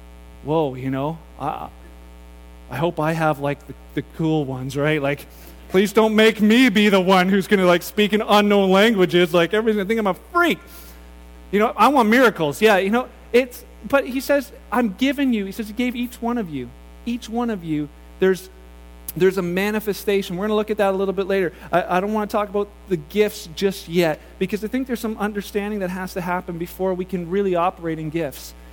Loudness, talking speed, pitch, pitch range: -20 LUFS, 215 wpm, 190 Hz, 150-210 Hz